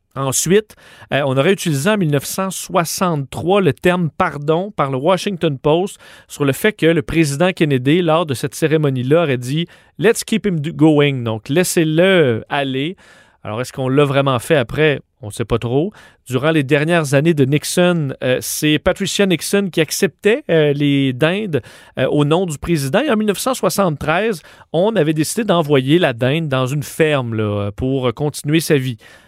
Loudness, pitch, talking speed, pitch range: -16 LUFS, 155 Hz, 170 wpm, 135-180 Hz